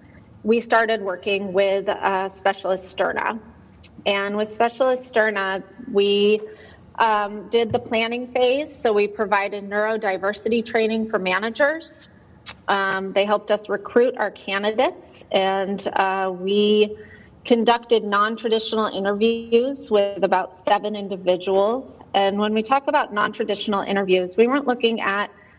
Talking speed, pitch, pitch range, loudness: 125 wpm, 210 Hz, 195-230 Hz, -21 LUFS